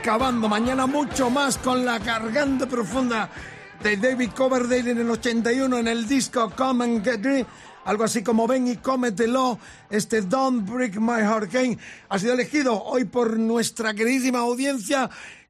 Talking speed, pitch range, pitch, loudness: 160 wpm, 230-260 Hz, 245 Hz, -23 LUFS